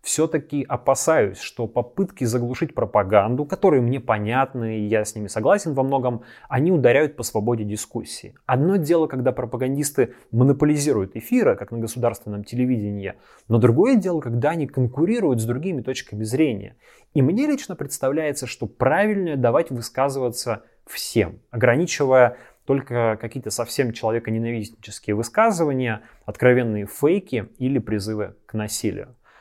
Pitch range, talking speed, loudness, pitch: 110-140 Hz, 125 wpm, -22 LUFS, 125 Hz